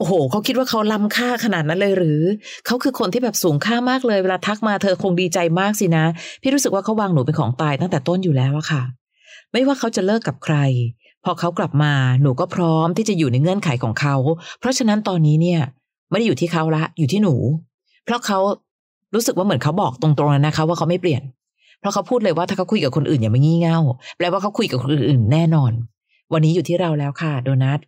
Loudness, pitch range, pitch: -19 LUFS, 150-205 Hz, 170 Hz